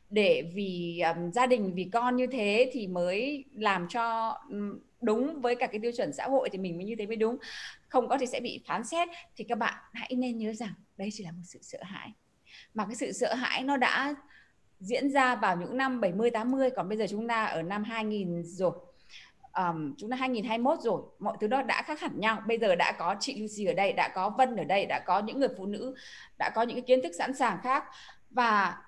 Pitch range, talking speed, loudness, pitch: 200-255 Hz, 235 wpm, -30 LUFS, 225 Hz